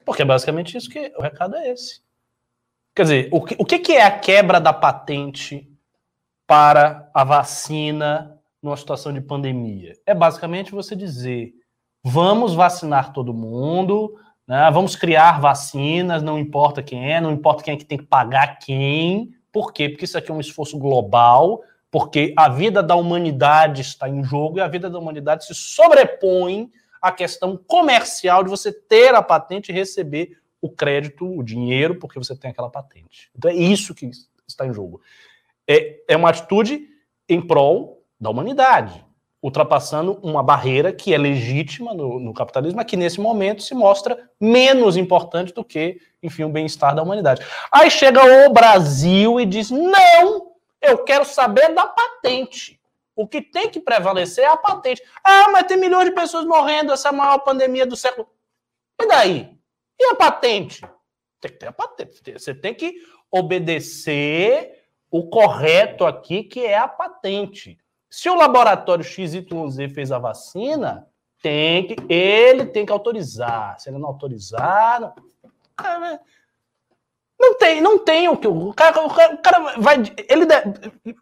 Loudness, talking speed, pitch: -16 LUFS, 165 wpm, 180 Hz